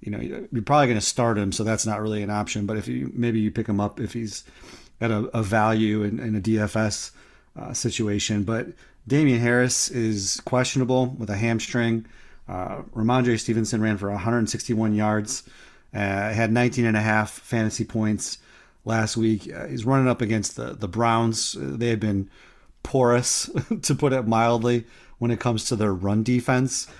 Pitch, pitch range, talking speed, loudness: 115 Hz, 105-120 Hz, 180 wpm, -24 LUFS